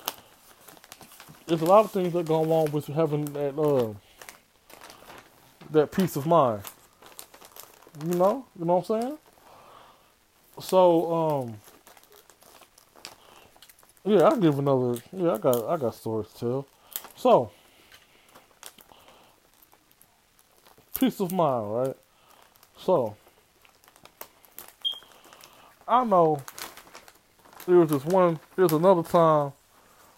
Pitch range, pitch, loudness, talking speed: 140-180 Hz, 165 Hz, -25 LUFS, 100 wpm